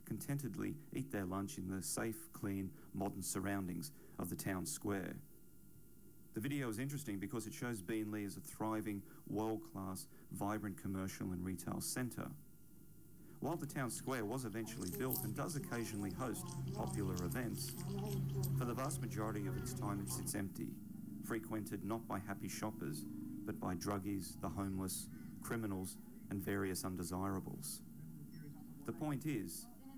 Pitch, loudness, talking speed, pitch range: 105 Hz, -44 LUFS, 145 wpm, 95-125 Hz